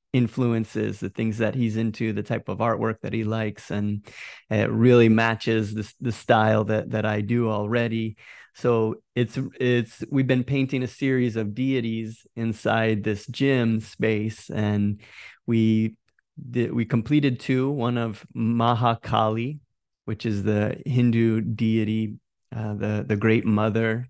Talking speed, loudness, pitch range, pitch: 145 wpm, -24 LUFS, 110-120 Hz, 115 Hz